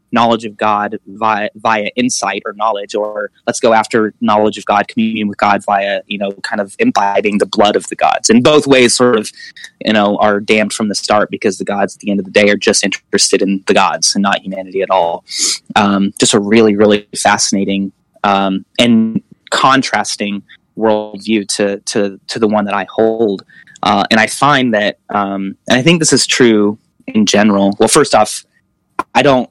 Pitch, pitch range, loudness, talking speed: 105 Hz, 100-110 Hz, -12 LUFS, 200 wpm